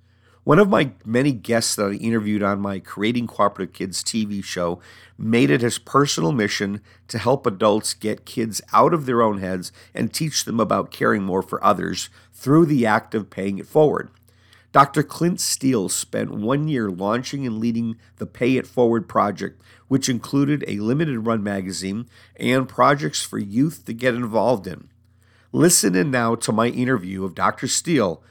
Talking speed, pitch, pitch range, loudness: 175 wpm, 110 Hz, 100-125 Hz, -21 LUFS